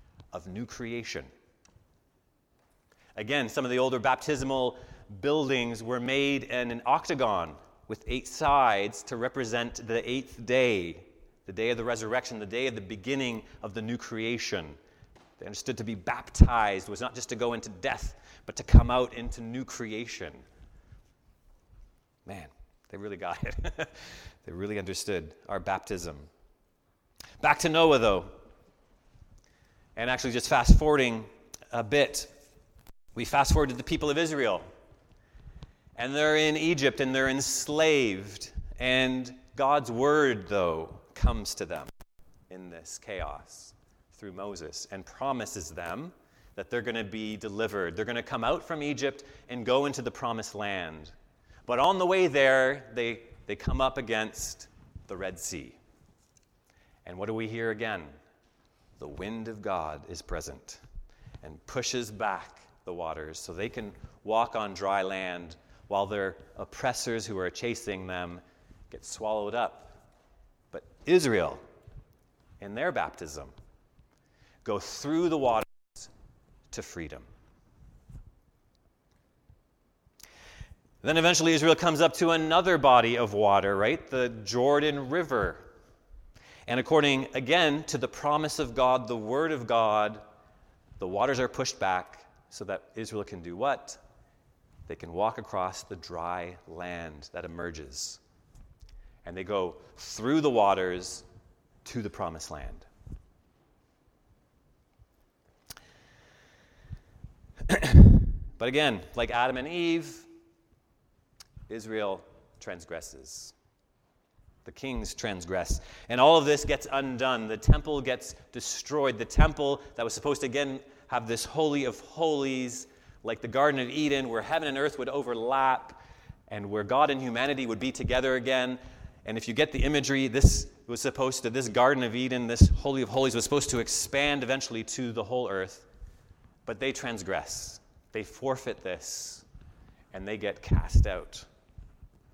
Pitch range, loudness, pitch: 105-135 Hz, -28 LUFS, 120 Hz